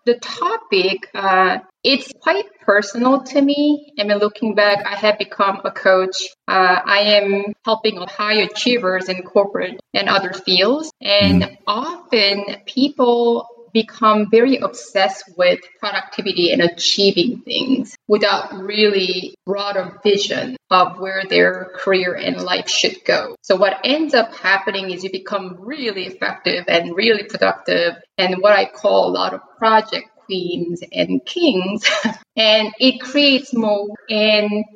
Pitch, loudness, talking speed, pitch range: 205 Hz, -17 LUFS, 140 wpm, 190-235 Hz